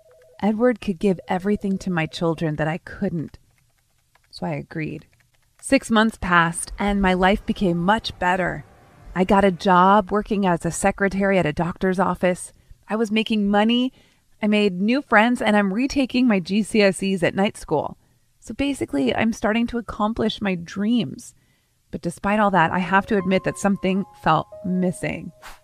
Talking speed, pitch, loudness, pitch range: 165 wpm, 200 Hz, -21 LUFS, 180-215 Hz